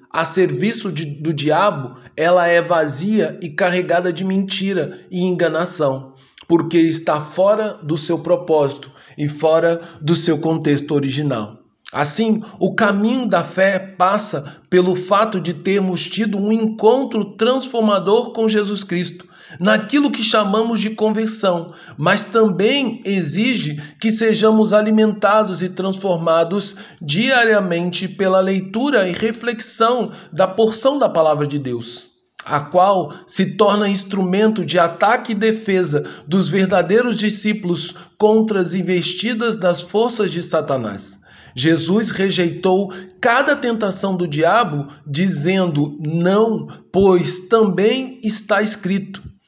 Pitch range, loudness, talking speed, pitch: 170-215 Hz, -17 LUFS, 120 wpm, 190 Hz